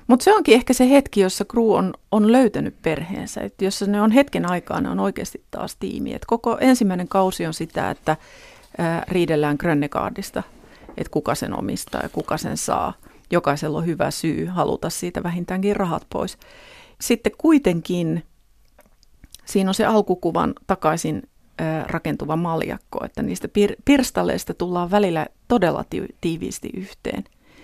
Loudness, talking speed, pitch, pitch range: -21 LUFS, 145 wpm, 195 Hz, 165-235 Hz